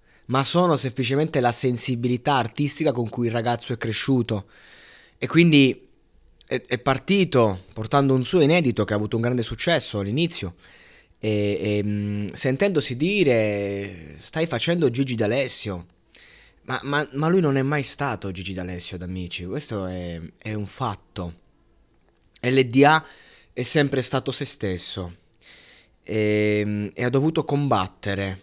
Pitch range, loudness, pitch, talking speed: 100-135 Hz, -22 LUFS, 120 Hz, 130 wpm